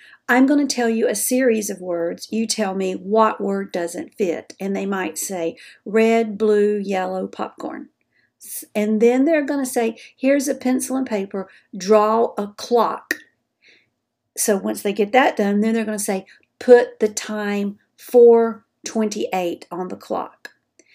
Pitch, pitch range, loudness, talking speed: 215 Hz, 200-240 Hz, -20 LUFS, 160 wpm